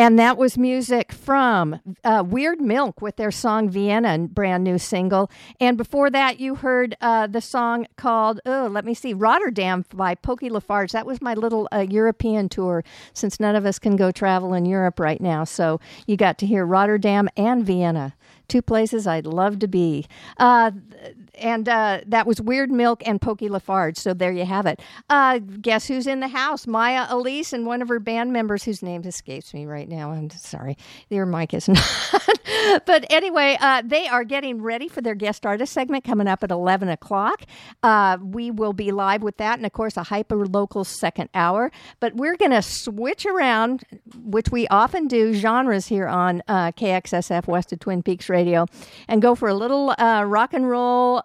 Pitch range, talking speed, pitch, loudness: 190-245 Hz, 195 wpm, 220 Hz, -21 LUFS